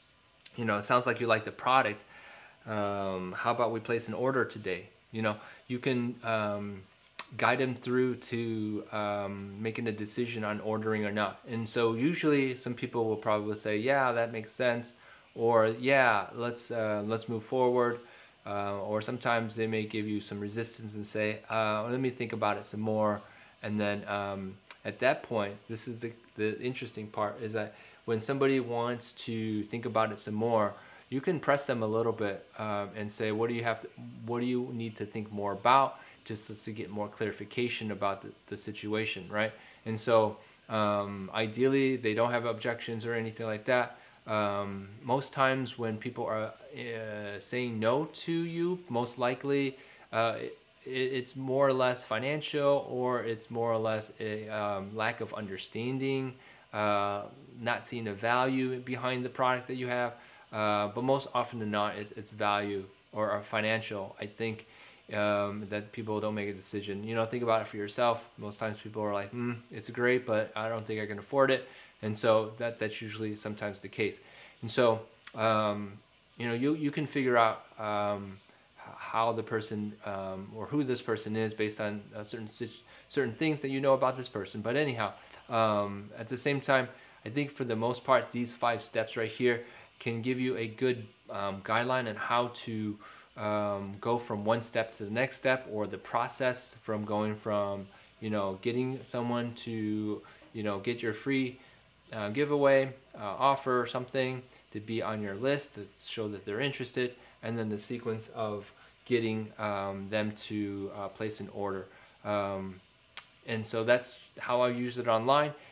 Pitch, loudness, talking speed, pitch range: 110 Hz, -32 LUFS, 185 wpm, 105-125 Hz